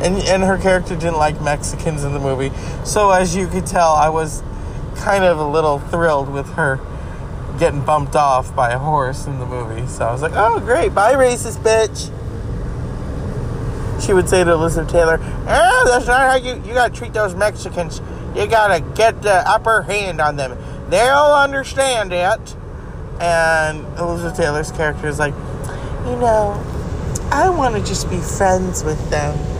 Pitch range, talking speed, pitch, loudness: 140-190 Hz, 175 wpm, 165 Hz, -17 LUFS